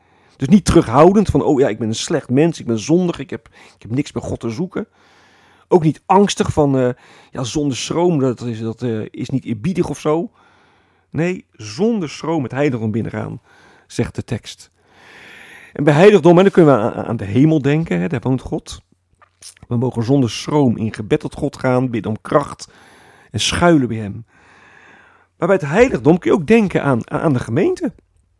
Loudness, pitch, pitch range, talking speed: -16 LUFS, 135 Hz, 115-165 Hz, 195 wpm